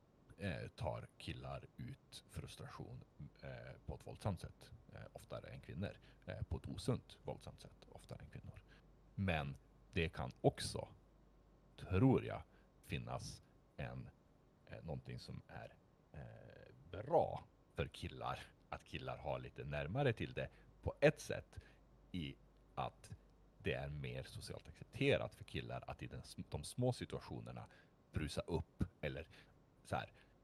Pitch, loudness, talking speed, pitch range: 70 Hz, -45 LUFS, 140 wpm, 65-85 Hz